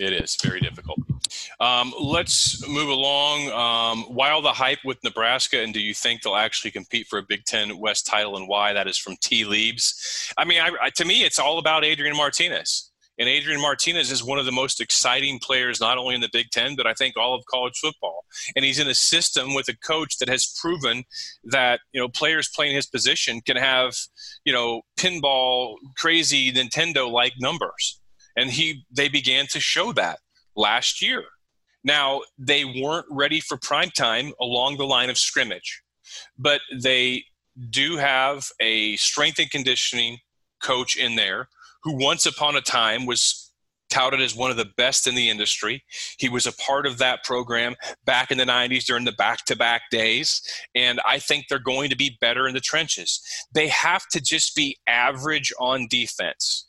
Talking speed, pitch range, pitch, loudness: 185 wpm, 125-150 Hz, 135 Hz, -21 LUFS